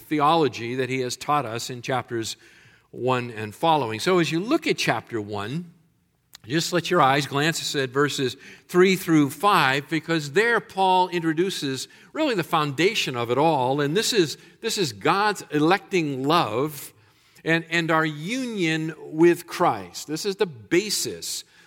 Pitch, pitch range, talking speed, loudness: 160 Hz, 135-180 Hz, 155 wpm, -23 LUFS